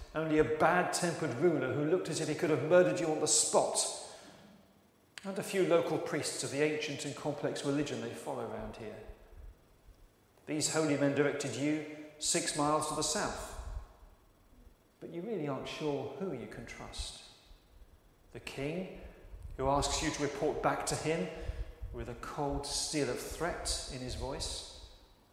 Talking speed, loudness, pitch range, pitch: 165 wpm, -33 LUFS, 130-155 Hz, 145 Hz